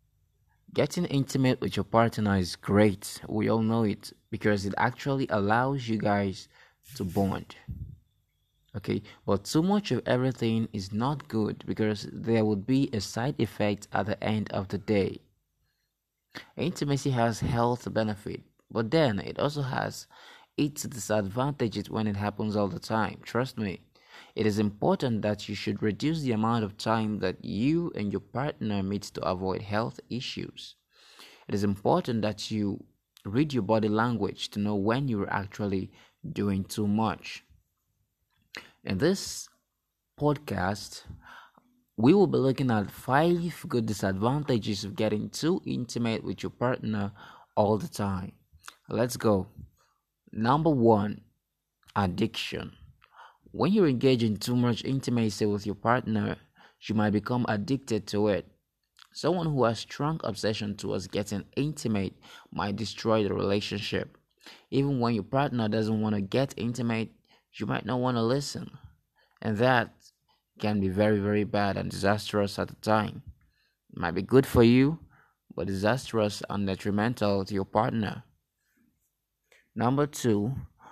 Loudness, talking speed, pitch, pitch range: -28 LUFS, 145 wpm, 110 Hz, 100-125 Hz